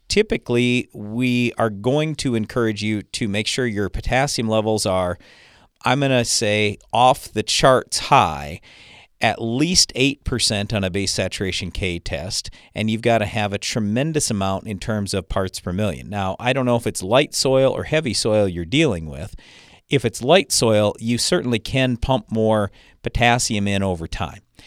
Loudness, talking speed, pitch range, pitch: -20 LUFS, 175 wpm, 100-125 Hz, 110 Hz